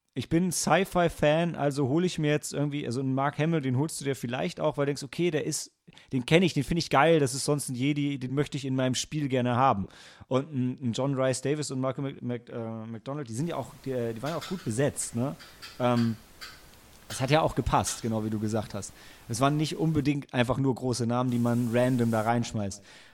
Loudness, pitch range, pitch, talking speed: -28 LUFS, 120-150 Hz, 135 Hz, 230 wpm